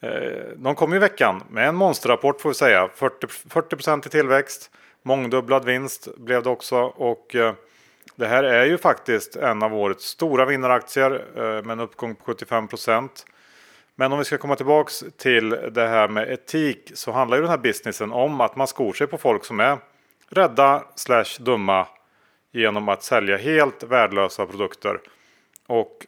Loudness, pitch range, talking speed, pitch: -21 LUFS, 115-140 Hz, 170 wpm, 130 Hz